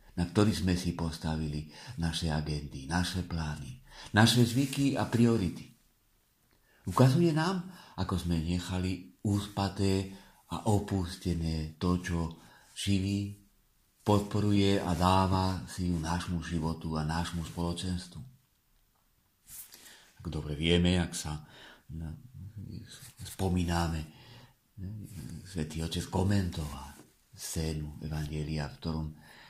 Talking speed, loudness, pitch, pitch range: 95 wpm, -31 LUFS, 90 Hz, 80-100 Hz